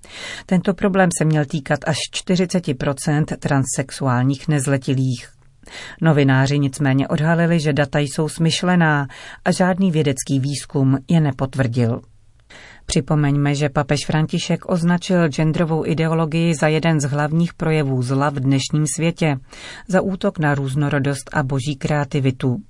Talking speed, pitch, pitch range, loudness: 120 wpm, 150 Hz, 140-165 Hz, -19 LUFS